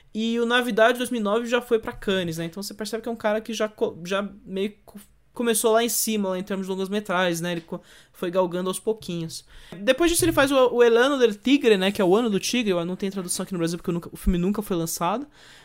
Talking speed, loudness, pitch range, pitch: 255 wpm, -23 LUFS, 185-230 Hz, 205 Hz